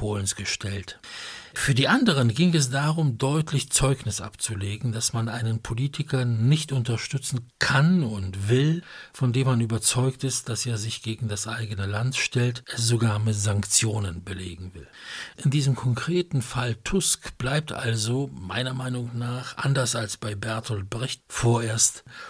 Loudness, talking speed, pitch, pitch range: -25 LUFS, 145 wpm, 120 Hz, 110-135 Hz